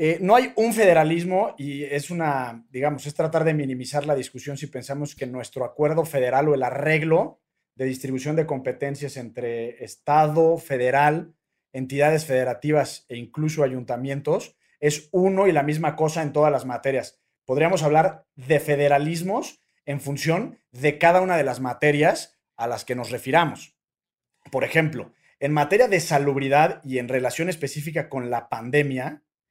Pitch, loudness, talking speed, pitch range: 145 Hz, -23 LUFS, 155 wpm, 130-160 Hz